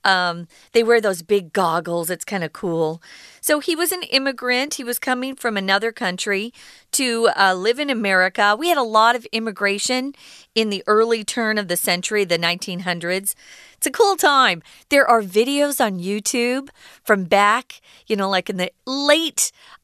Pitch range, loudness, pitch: 190-255 Hz, -19 LUFS, 220 Hz